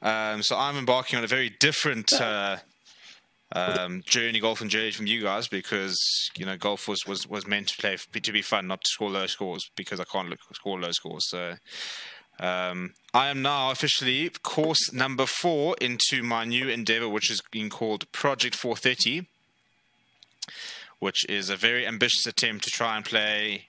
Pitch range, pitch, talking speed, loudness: 100-125 Hz, 110 Hz, 185 wpm, -26 LUFS